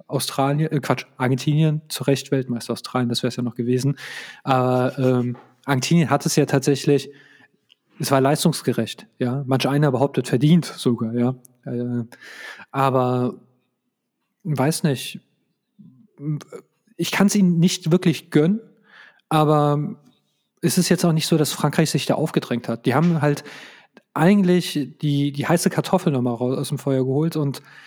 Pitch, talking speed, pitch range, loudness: 145 Hz, 155 wpm, 130-160 Hz, -21 LUFS